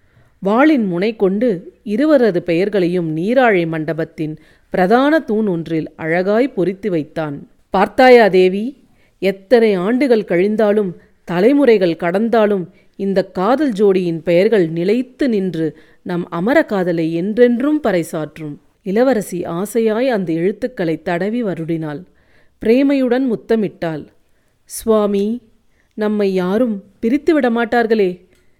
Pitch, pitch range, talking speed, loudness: 200 Hz, 175-235 Hz, 90 wpm, -16 LUFS